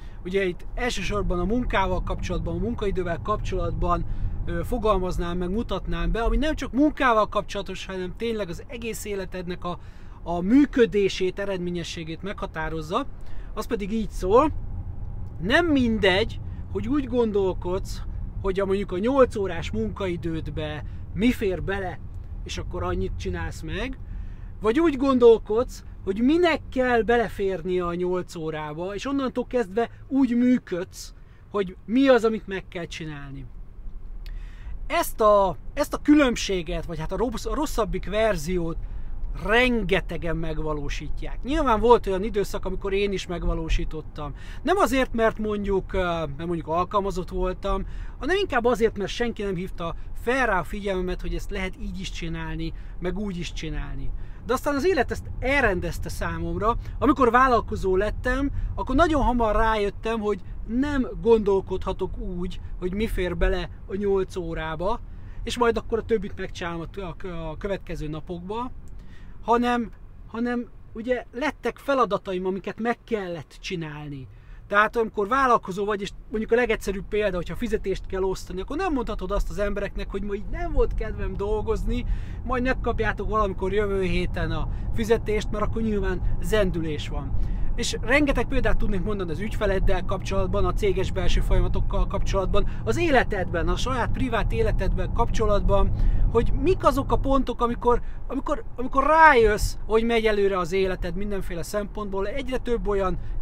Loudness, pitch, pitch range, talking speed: -25 LUFS, 195 Hz, 160-230 Hz, 140 wpm